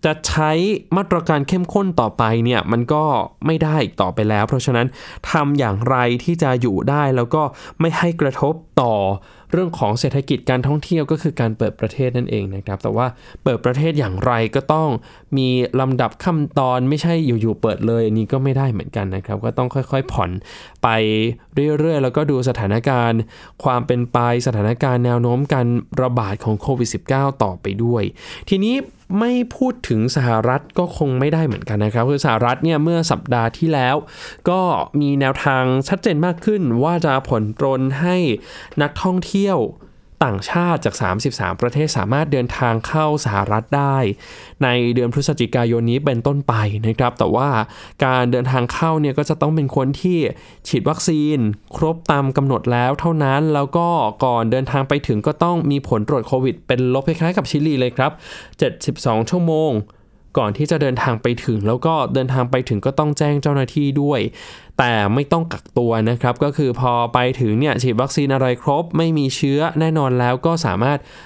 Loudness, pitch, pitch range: -18 LUFS, 135 Hz, 120-155 Hz